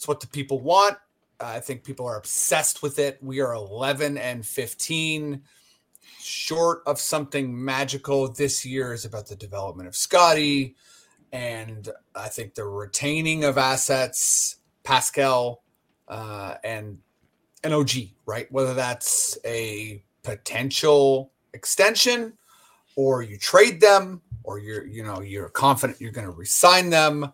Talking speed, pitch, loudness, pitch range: 140 wpm, 135 Hz, -22 LUFS, 115-150 Hz